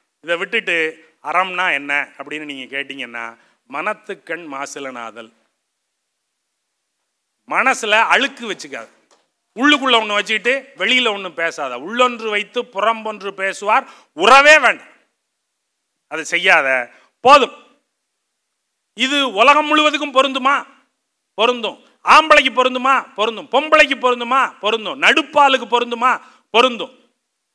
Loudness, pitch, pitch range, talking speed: -15 LUFS, 235 Hz, 185-265 Hz, 90 wpm